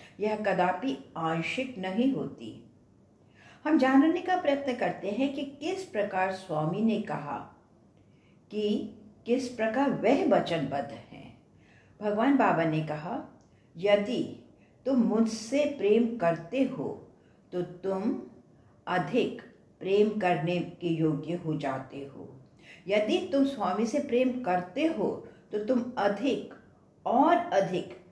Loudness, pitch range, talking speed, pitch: -29 LUFS, 180-265 Hz, 115 wpm, 210 Hz